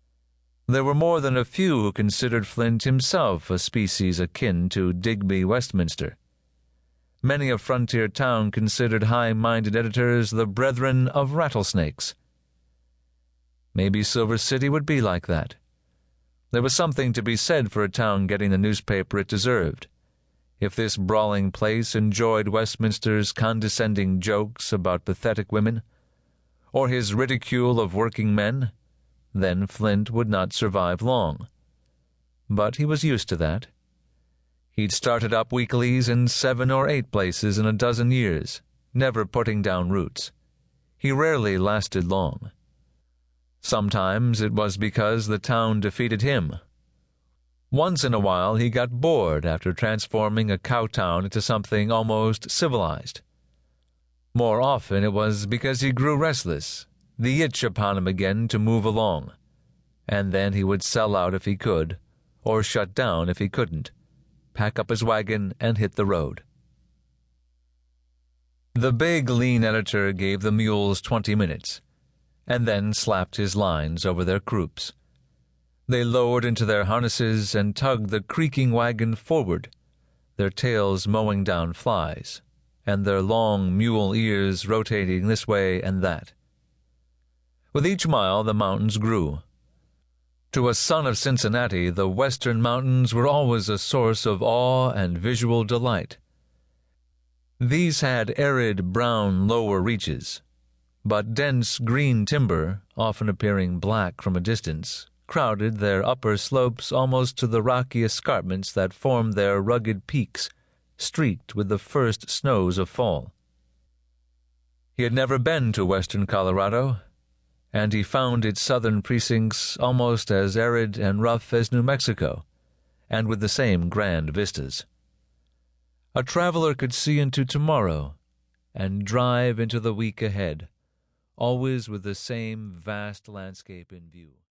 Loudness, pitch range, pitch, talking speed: -24 LUFS, 85-120 Hz, 105 Hz, 140 wpm